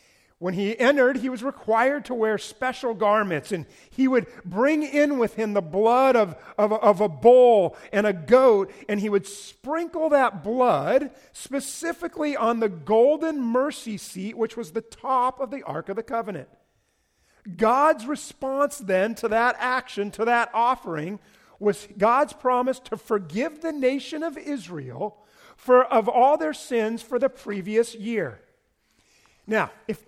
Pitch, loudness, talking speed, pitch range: 230 Hz, -23 LUFS, 155 wpm, 210-265 Hz